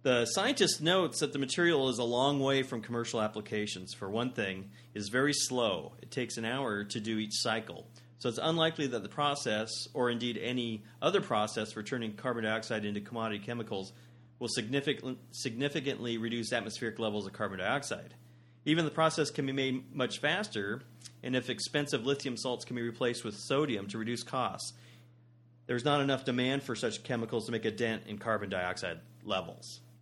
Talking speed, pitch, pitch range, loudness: 180 wpm, 120 Hz, 110-135 Hz, -33 LUFS